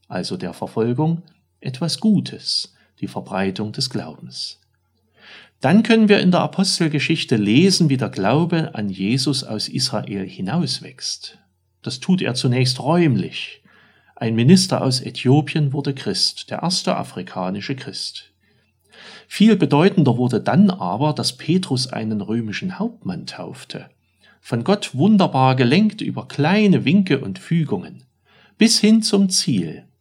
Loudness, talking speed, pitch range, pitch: -19 LUFS, 125 wpm, 125-190 Hz, 150 Hz